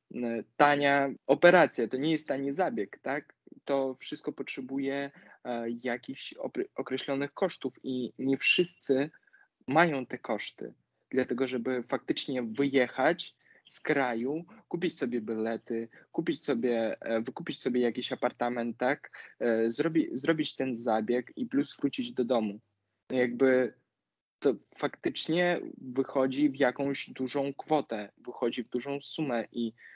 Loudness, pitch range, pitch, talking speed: -30 LUFS, 120-145 Hz, 130 Hz, 120 wpm